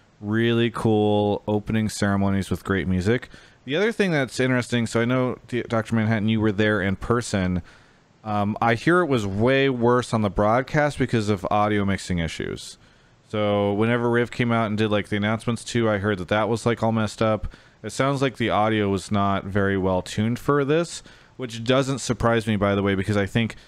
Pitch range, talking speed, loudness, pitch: 105-120 Hz, 200 wpm, -23 LUFS, 110 Hz